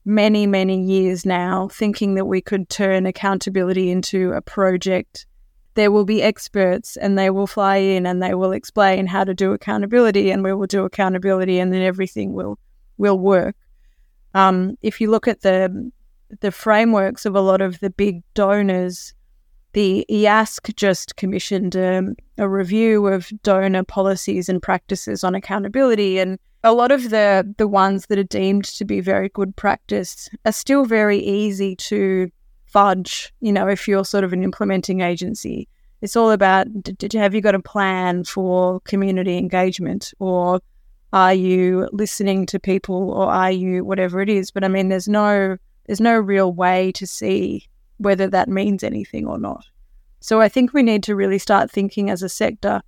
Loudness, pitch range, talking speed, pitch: -18 LUFS, 185-205 Hz, 175 wpm, 195 Hz